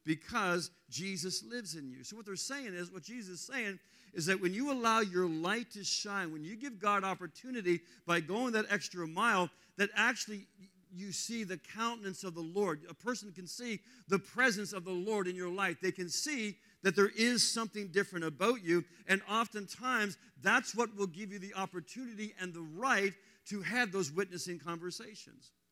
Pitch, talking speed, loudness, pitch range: 195 Hz, 190 wpm, -35 LUFS, 180-225 Hz